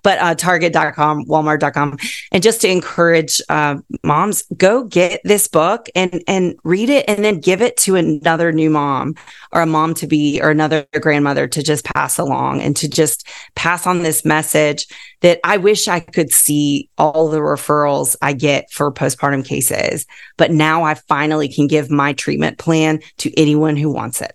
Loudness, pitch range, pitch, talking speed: -15 LUFS, 150-175 Hz, 155 Hz, 180 wpm